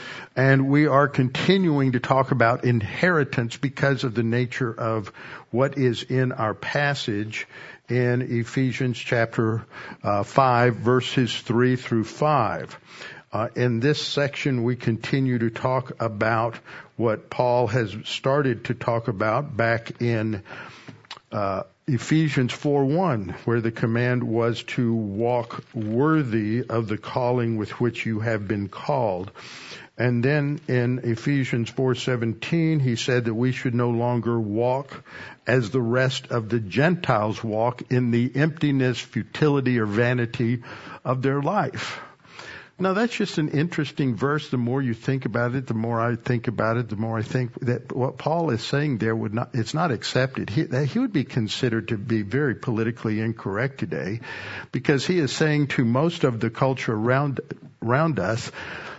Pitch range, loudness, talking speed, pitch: 115-140 Hz, -24 LUFS, 155 wpm, 125 Hz